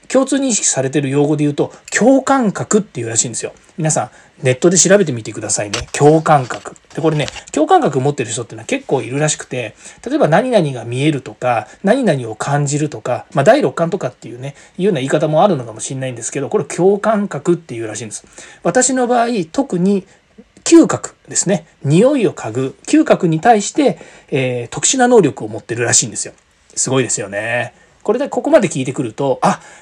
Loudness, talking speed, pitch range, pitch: -15 LUFS, 415 characters per minute, 135-210 Hz, 160 Hz